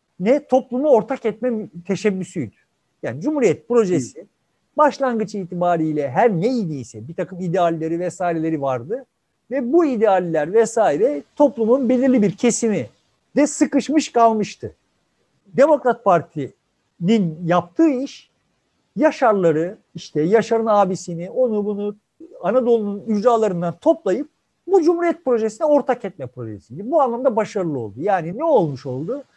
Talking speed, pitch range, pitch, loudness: 110 wpm, 175-255 Hz, 215 Hz, -19 LUFS